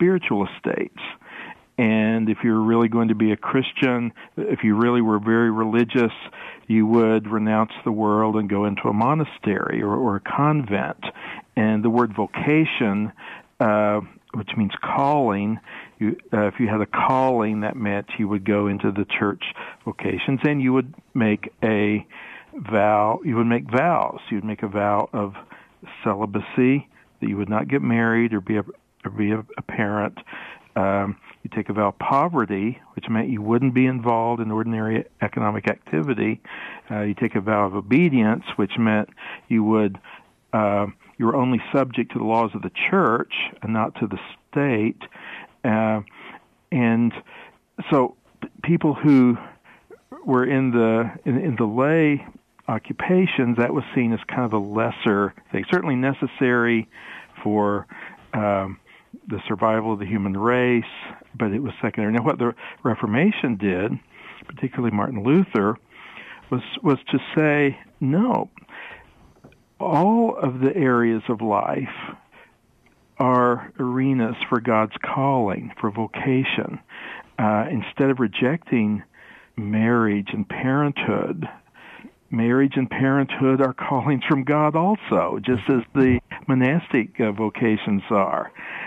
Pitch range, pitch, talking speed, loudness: 105-130 Hz, 115 Hz, 145 wpm, -22 LUFS